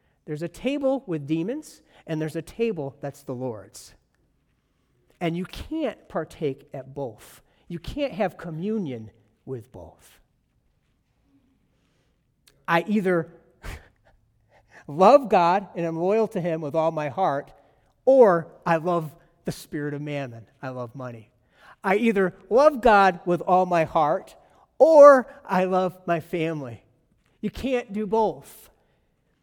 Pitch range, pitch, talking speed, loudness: 135-190 Hz, 165 Hz, 130 wpm, -23 LUFS